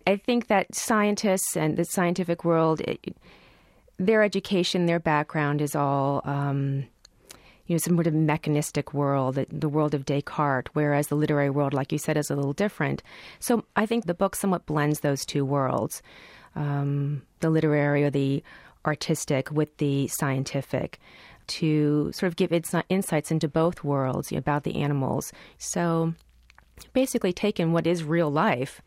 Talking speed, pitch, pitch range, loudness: 165 wpm, 155 Hz, 145-175 Hz, -26 LUFS